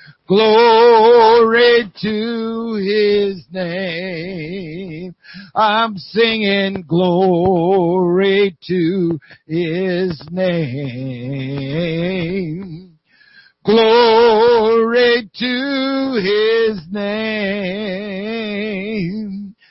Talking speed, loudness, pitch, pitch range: 45 wpm, -15 LUFS, 195 Hz, 180-225 Hz